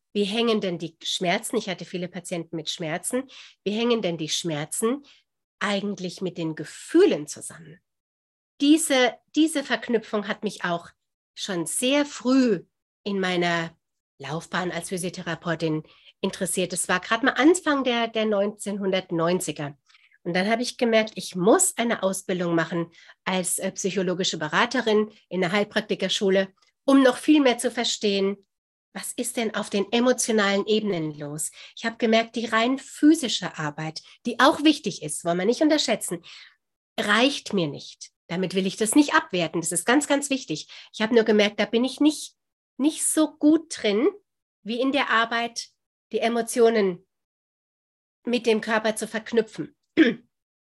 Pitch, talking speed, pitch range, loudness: 210 Hz, 150 wpm, 180-245 Hz, -24 LUFS